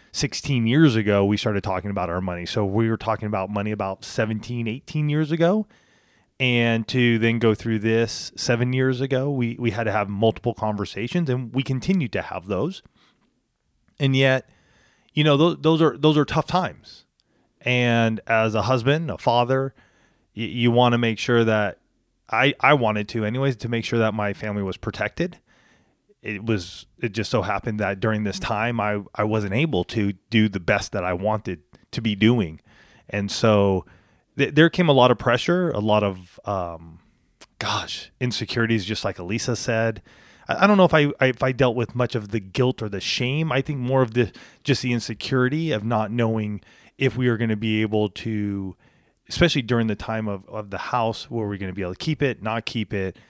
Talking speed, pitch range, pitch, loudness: 205 wpm, 105-130 Hz, 115 Hz, -22 LUFS